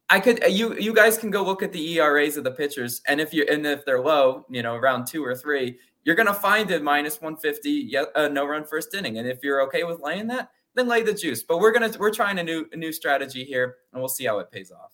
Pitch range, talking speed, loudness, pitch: 140-210 Hz, 275 wpm, -23 LUFS, 155 Hz